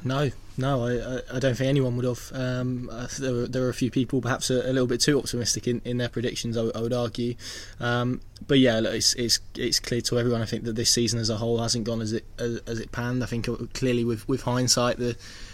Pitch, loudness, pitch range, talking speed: 120 Hz, -26 LUFS, 115-125 Hz, 250 wpm